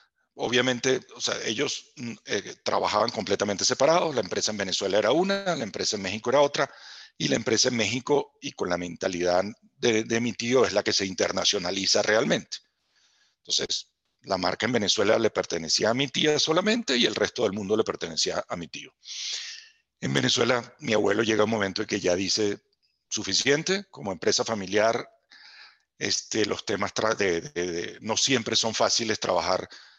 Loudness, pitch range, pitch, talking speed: -25 LUFS, 100-140 Hz, 115 Hz, 175 wpm